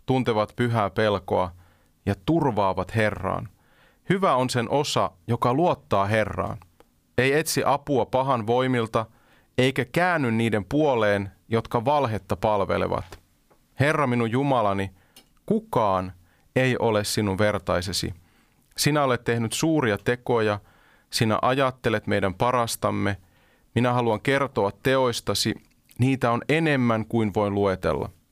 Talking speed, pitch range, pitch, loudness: 110 wpm, 100-130 Hz, 115 Hz, -24 LUFS